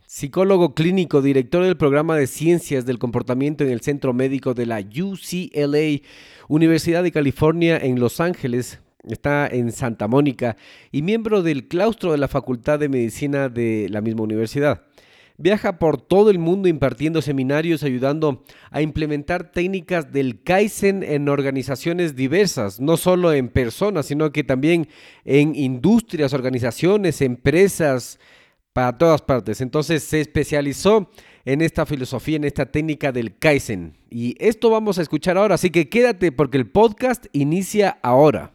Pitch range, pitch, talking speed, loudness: 130-170 Hz, 150 Hz, 145 wpm, -19 LUFS